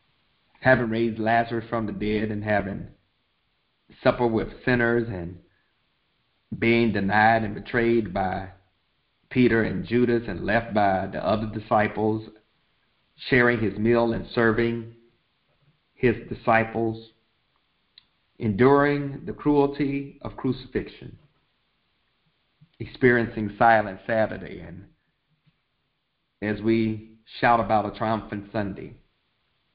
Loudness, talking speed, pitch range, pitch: -24 LUFS, 100 wpm, 105-120 Hz, 115 Hz